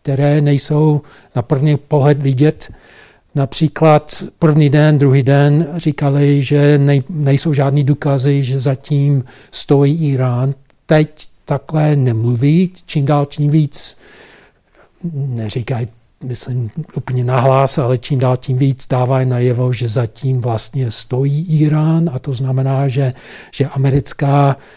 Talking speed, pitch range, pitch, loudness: 115 wpm, 130-150 Hz, 140 Hz, -14 LUFS